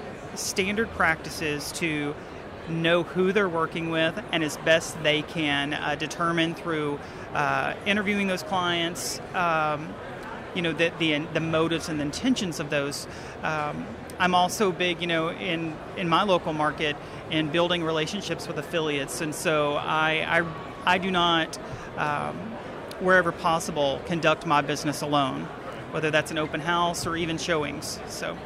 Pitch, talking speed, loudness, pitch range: 165 Hz, 150 wpm, -26 LUFS, 150-175 Hz